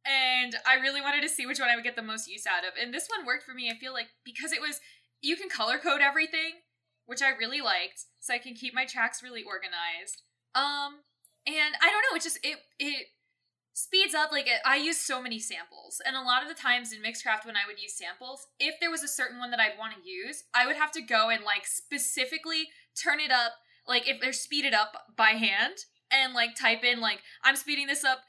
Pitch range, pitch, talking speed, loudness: 230-290 Hz, 260 Hz, 240 wpm, -28 LUFS